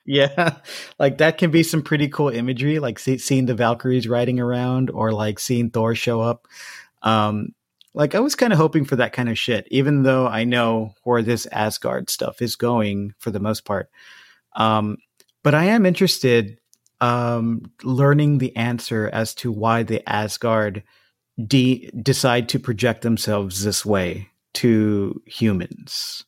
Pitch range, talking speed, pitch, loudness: 110-135 Hz, 160 wpm, 120 Hz, -20 LUFS